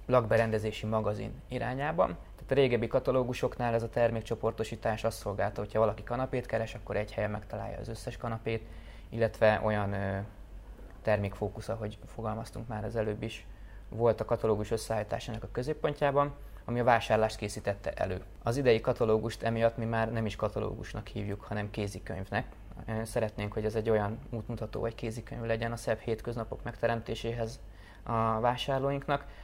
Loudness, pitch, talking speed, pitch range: -32 LUFS, 110 Hz, 145 wpm, 105-115 Hz